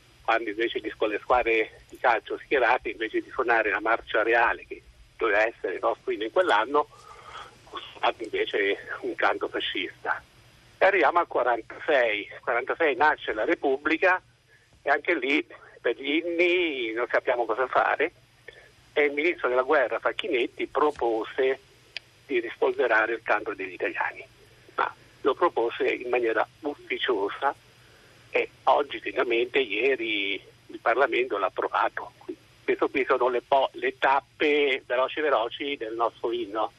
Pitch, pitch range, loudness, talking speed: 380 Hz, 335-420 Hz, -26 LUFS, 135 wpm